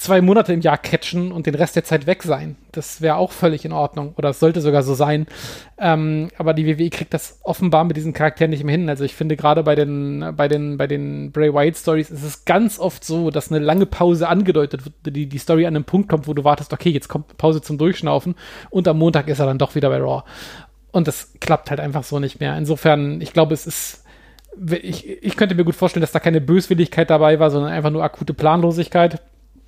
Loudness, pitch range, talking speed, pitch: -18 LUFS, 150-170 Hz, 235 wpm, 155 Hz